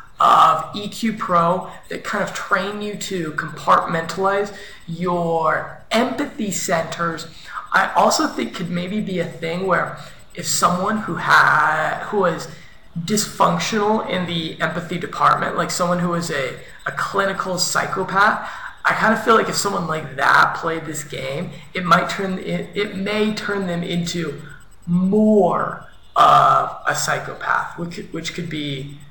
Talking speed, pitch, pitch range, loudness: 145 wpm, 175 Hz, 165-200 Hz, -19 LUFS